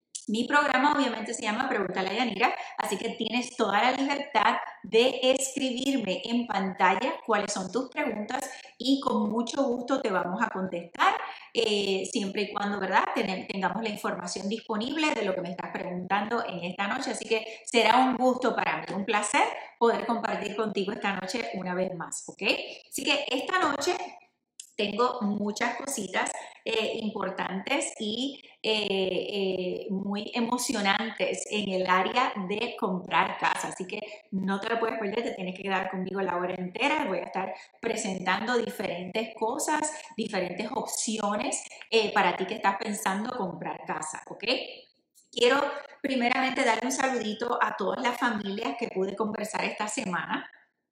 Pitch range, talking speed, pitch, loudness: 195-255 Hz, 155 wpm, 225 Hz, -28 LUFS